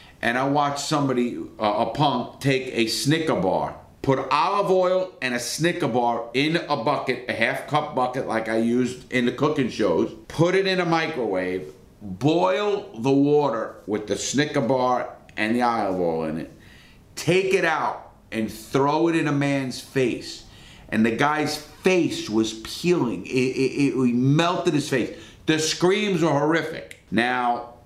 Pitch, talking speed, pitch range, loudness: 135 Hz, 165 wpm, 120-155 Hz, -23 LUFS